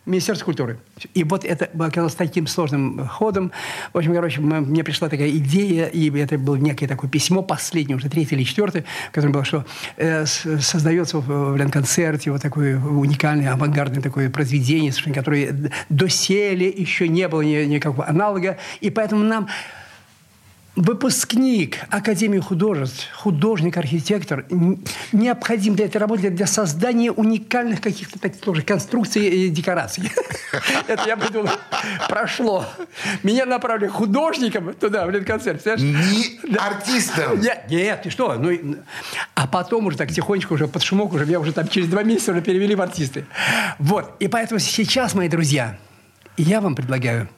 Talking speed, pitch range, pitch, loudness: 135 wpm, 150-205 Hz, 175 Hz, -20 LUFS